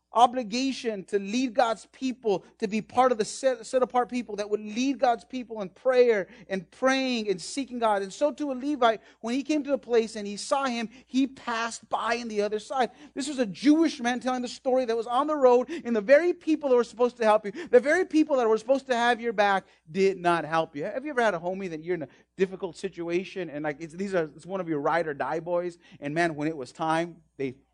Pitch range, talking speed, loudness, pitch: 190-255 Hz, 250 wpm, -27 LUFS, 230 Hz